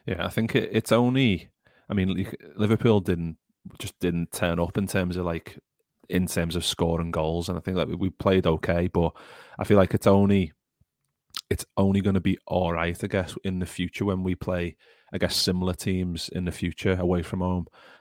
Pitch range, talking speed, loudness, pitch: 85-100 Hz, 200 wpm, -26 LUFS, 90 Hz